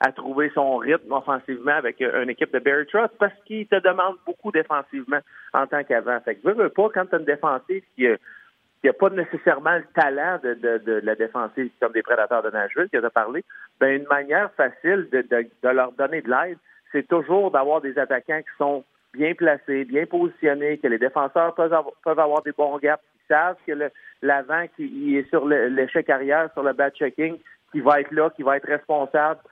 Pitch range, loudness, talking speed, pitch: 140-170 Hz, -22 LUFS, 210 wpm, 150 Hz